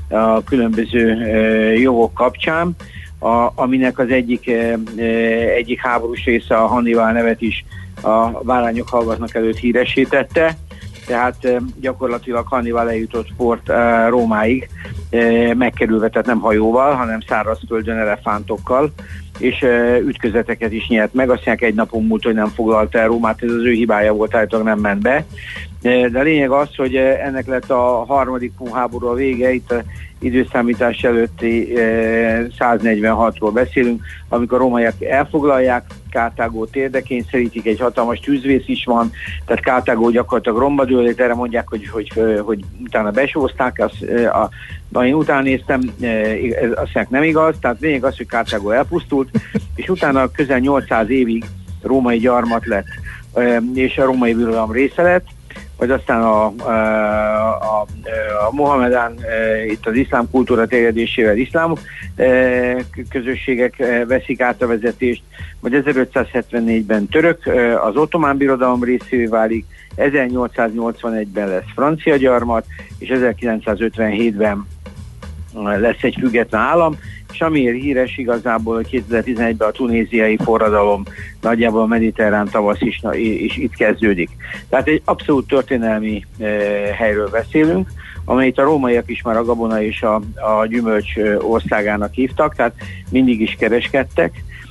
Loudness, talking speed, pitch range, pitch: -16 LUFS, 135 wpm, 110-125 Hz, 115 Hz